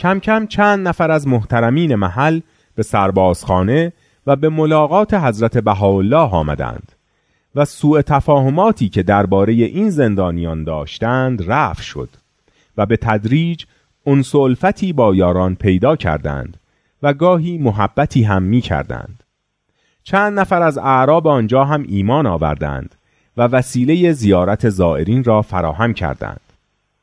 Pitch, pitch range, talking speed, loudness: 120 Hz, 95-155 Hz, 120 wpm, -15 LUFS